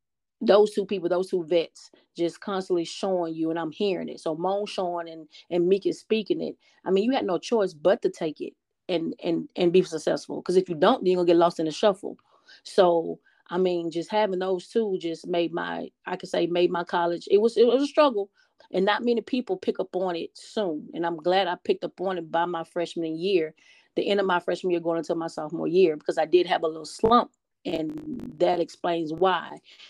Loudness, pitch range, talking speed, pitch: -26 LUFS, 170-205 Hz, 230 wpm, 180 Hz